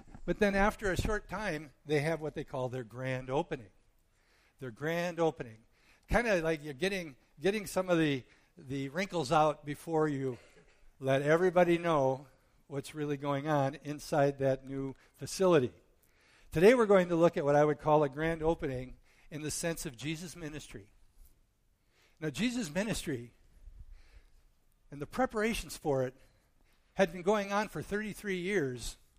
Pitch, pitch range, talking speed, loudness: 150 Hz, 130-170 Hz, 155 wpm, -32 LUFS